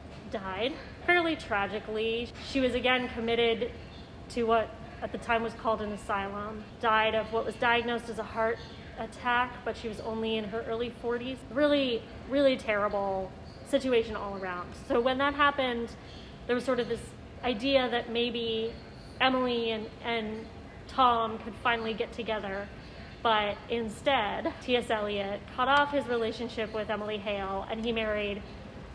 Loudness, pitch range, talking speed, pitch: -30 LUFS, 220-245 Hz, 150 wpm, 230 Hz